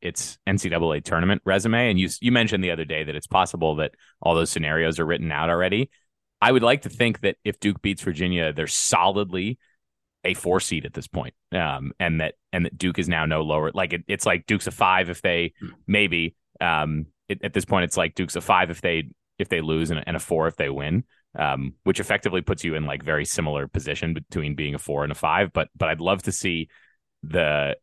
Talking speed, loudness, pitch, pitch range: 230 wpm, -24 LUFS, 85 Hz, 80-95 Hz